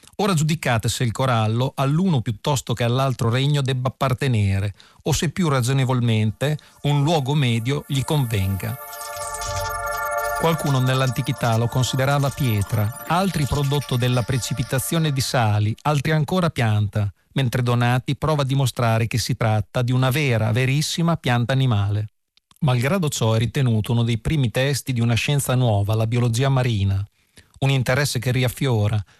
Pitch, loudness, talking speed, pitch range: 130 Hz, -21 LUFS, 140 wpm, 115-140 Hz